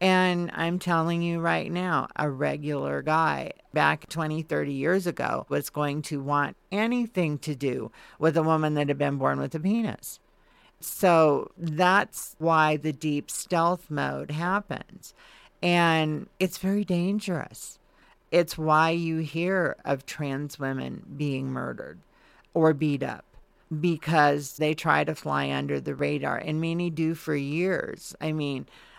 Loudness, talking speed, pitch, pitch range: -26 LUFS, 145 wpm, 160 Hz, 145-175 Hz